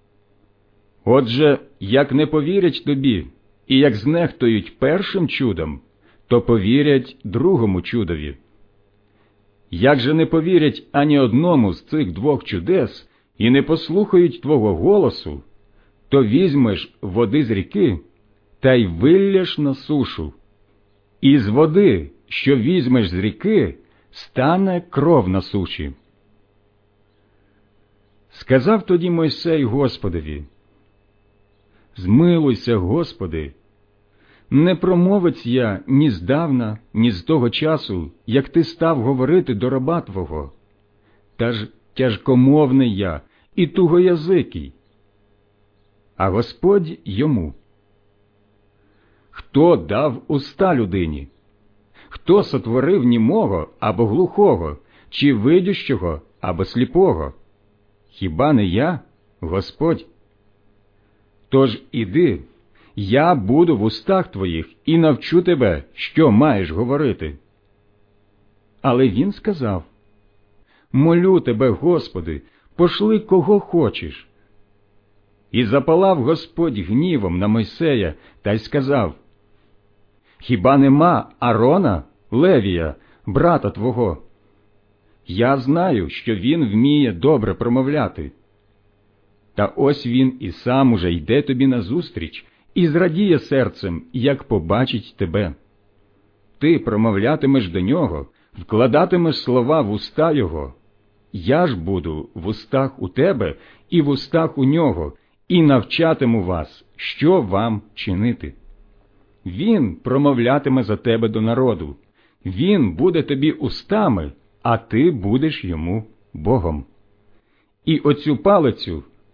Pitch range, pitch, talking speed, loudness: 100-140 Hz, 110 Hz, 100 wpm, -18 LUFS